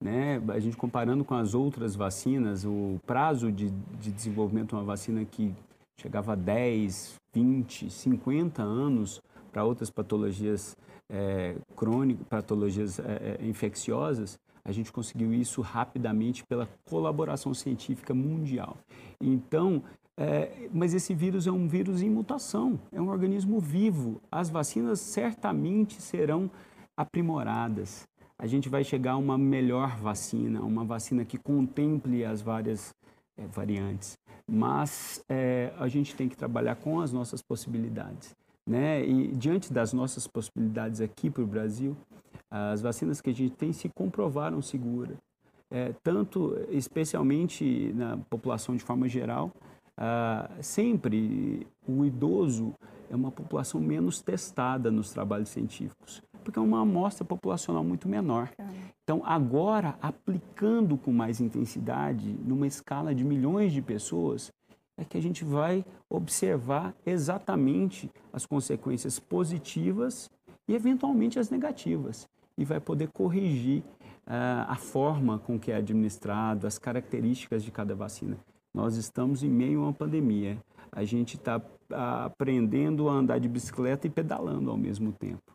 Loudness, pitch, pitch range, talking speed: -30 LUFS, 125 Hz, 110-150 Hz, 135 wpm